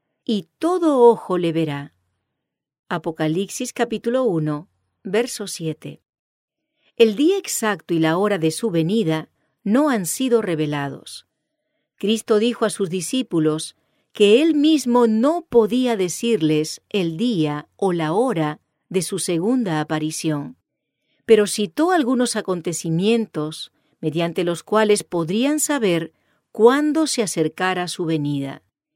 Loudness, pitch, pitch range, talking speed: -20 LUFS, 195 Hz, 160-235 Hz, 120 wpm